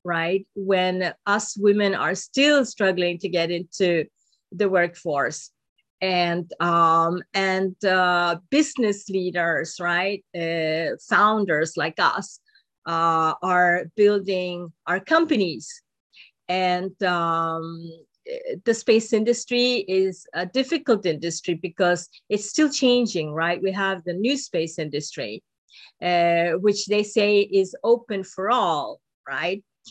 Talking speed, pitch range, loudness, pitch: 115 wpm, 170-210 Hz, -22 LUFS, 185 Hz